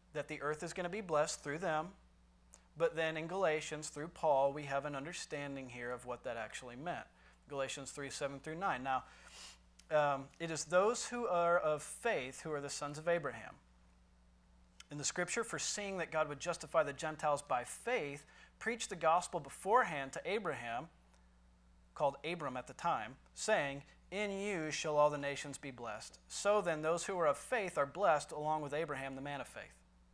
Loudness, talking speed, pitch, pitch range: -38 LUFS, 185 wpm, 145 Hz, 135-165 Hz